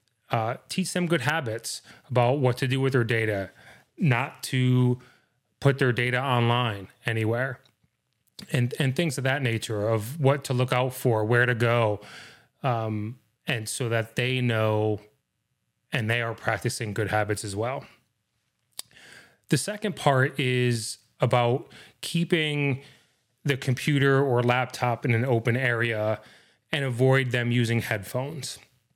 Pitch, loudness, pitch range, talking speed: 125 Hz, -26 LUFS, 115-135 Hz, 140 wpm